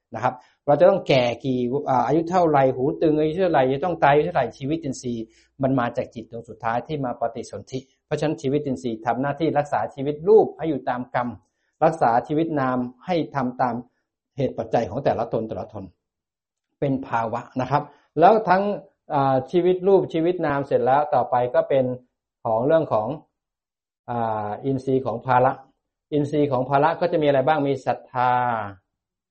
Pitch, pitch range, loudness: 135 Hz, 120-155 Hz, -22 LUFS